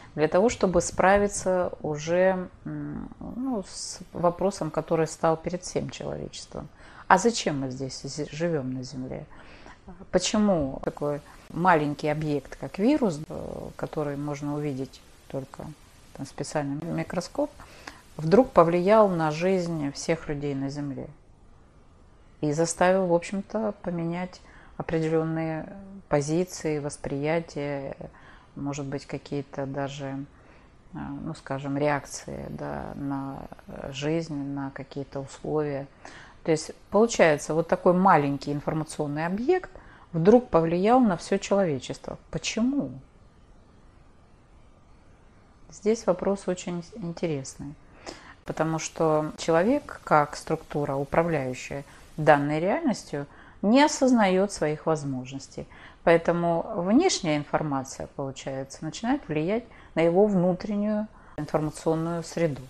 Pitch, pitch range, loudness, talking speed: 160 Hz, 145-185 Hz, -26 LUFS, 100 wpm